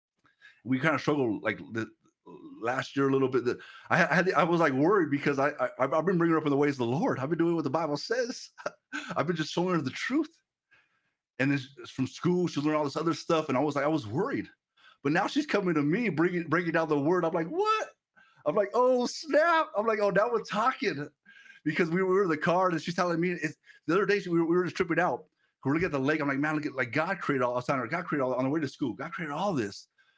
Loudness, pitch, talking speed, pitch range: -28 LUFS, 165 Hz, 270 wpm, 145-190 Hz